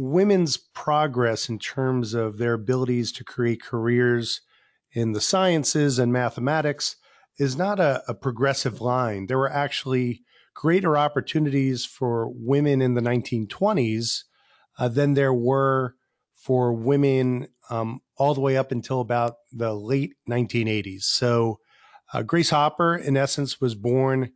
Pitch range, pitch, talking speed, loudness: 120-140 Hz, 130 Hz, 135 wpm, -24 LUFS